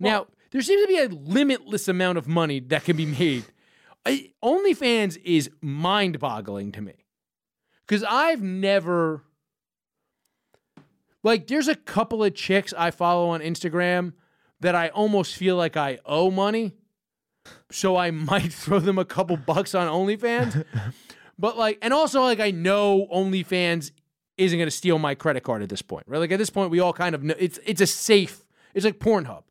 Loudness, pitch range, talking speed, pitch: -23 LUFS, 165-210 Hz, 175 wpm, 185 Hz